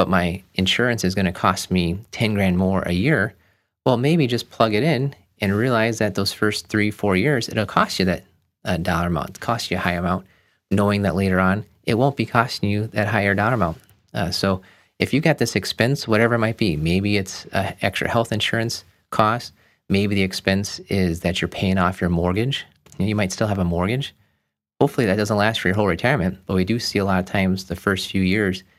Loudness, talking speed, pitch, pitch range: -21 LUFS, 220 wpm, 100 Hz, 95-110 Hz